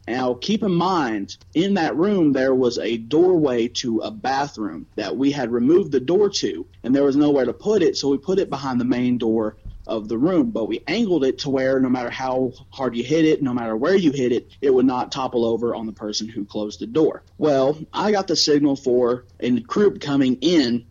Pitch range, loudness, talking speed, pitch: 120-155 Hz, -21 LUFS, 230 wpm, 130 Hz